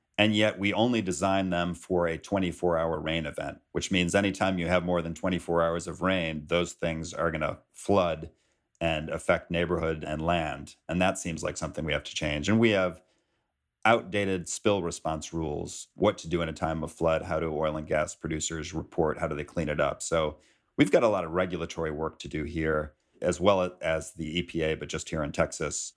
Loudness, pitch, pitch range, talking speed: -29 LUFS, 85 Hz, 80-90 Hz, 215 wpm